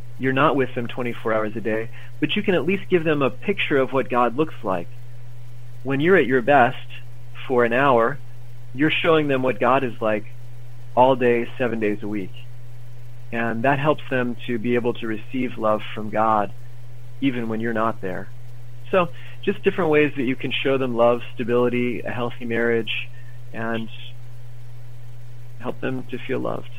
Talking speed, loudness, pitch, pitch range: 180 wpm, -22 LUFS, 120 Hz, 120-130 Hz